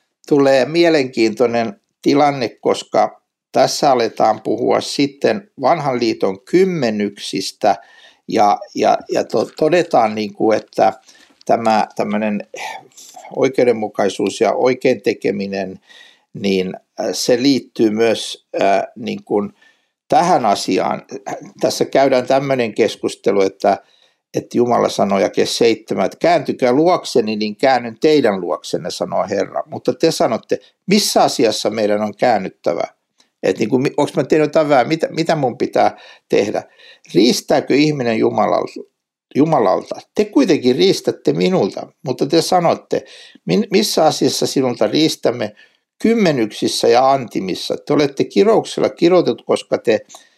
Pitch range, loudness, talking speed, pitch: 110-170 Hz, -16 LUFS, 110 wpm, 135 Hz